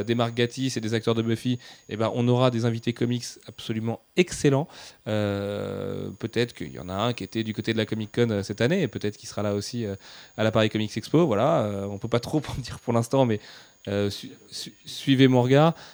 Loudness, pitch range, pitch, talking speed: -25 LUFS, 105-125 Hz, 115 Hz, 230 wpm